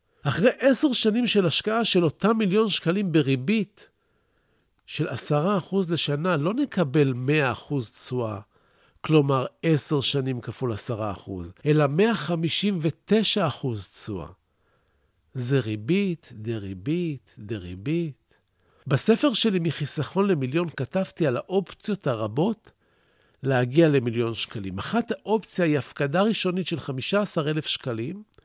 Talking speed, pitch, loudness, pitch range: 120 wpm, 155 Hz, -24 LUFS, 125-190 Hz